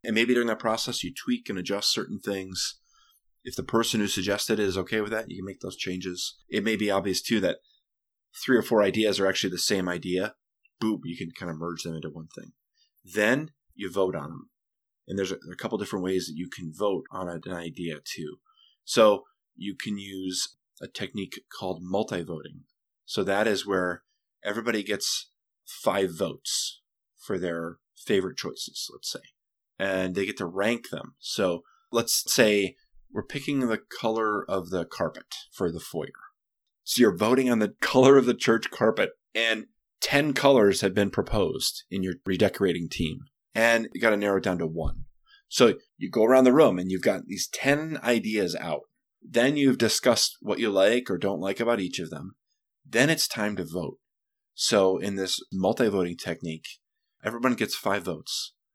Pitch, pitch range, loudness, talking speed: 100 Hz, 95-120 Hz, -26 LUFS, 190 wpm